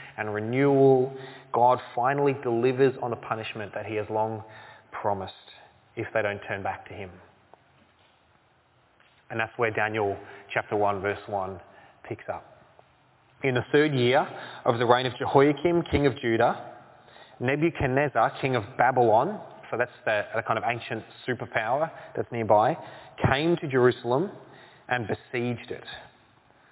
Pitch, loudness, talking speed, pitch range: 120 Hz, -26 LUFS, 135 wpm, 110-135 Hz